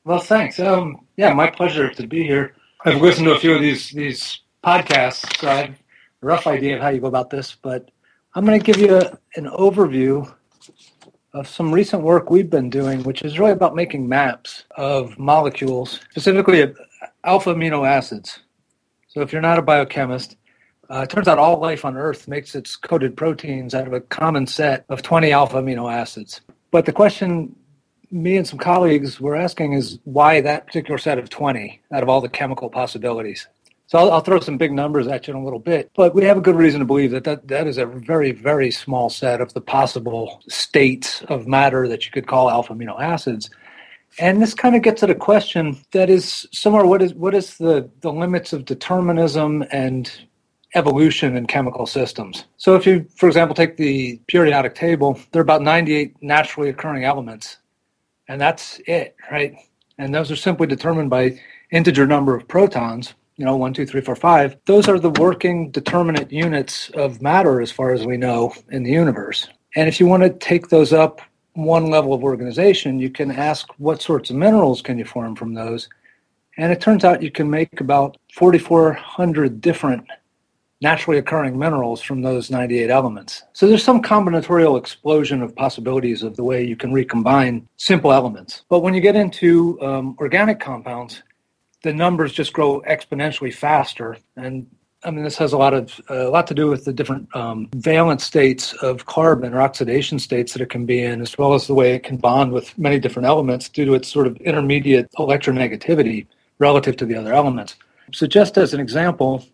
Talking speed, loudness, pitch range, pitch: 195 wpm, -17 LUFS, 130-165 Hz, 145 Hz